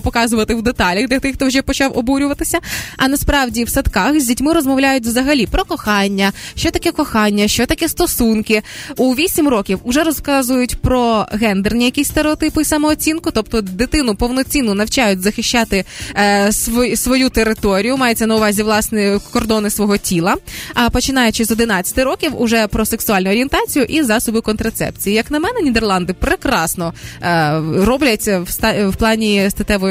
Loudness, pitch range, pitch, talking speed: -15 LUFS, 210-275 Hz, 235 Hz, 145 wpm